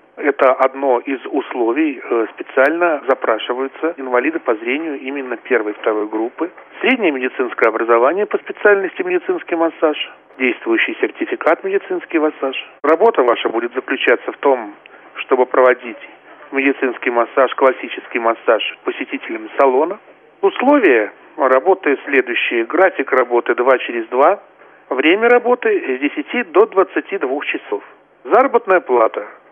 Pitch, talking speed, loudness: 235 Hz, 115 wpm, -16 LUFS